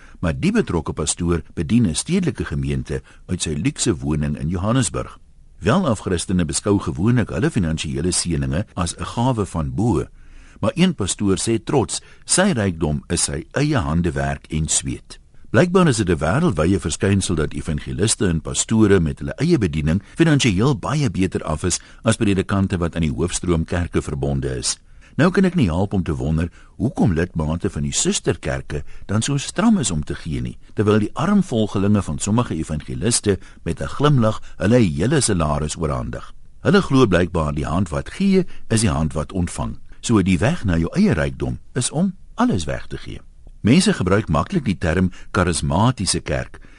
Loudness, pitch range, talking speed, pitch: -20 LUFS, 75-110 Hz, 170 wpm, 90 Hz